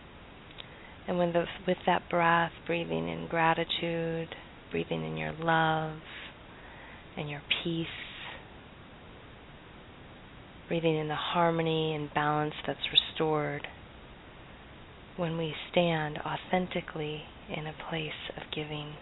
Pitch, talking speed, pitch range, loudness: 160 Hz, 100 wpm, 150-170 Hz, -31 LUFS